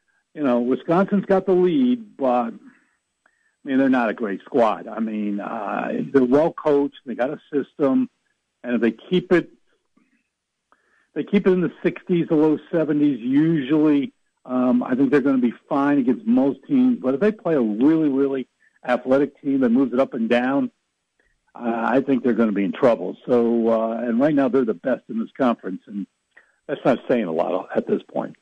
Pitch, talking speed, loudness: 150 Hz, 200 wpm, -21 LUFS